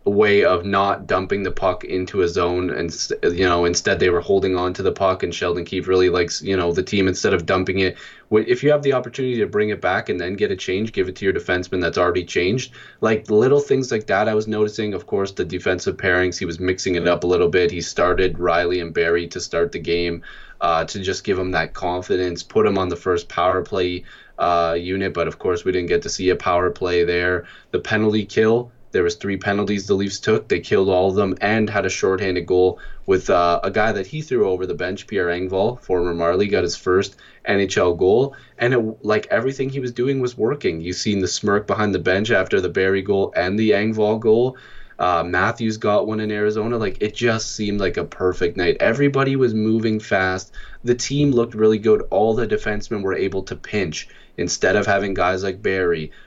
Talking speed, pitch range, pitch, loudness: 225 wpm, 90-110 Hz, 100 Hz, -20 LUFS